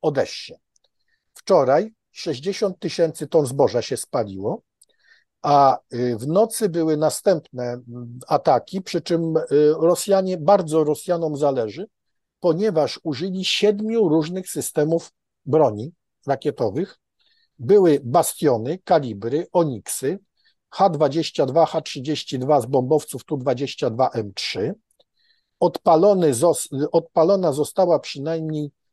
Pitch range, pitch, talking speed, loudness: 145-185 Hz, 160 Hz, 80 wpm, -21 LUFS